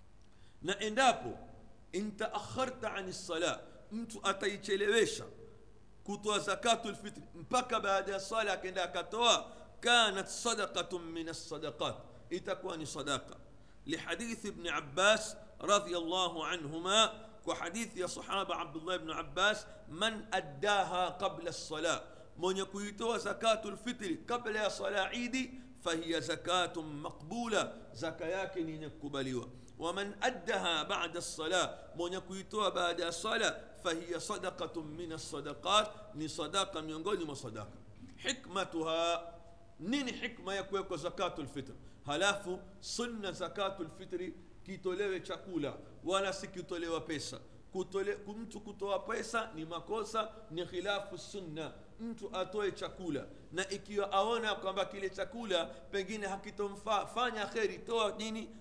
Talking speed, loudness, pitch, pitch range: 105 wpm, -36 LUFS, 190 Hz, 170-215 Hz